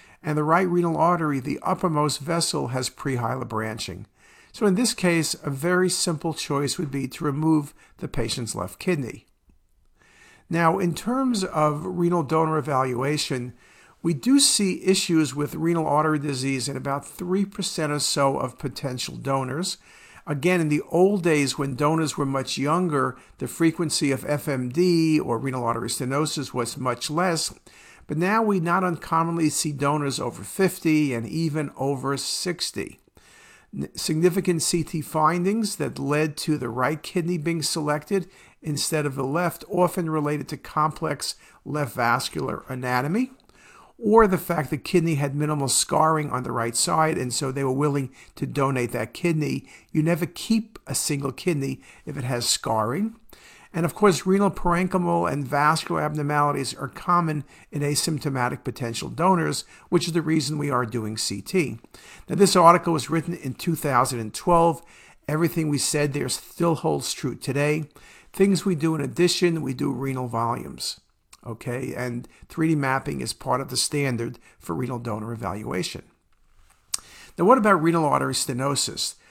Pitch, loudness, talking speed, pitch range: 150 Hz, -24 LUFS, 155 wpm, 135-170 Hz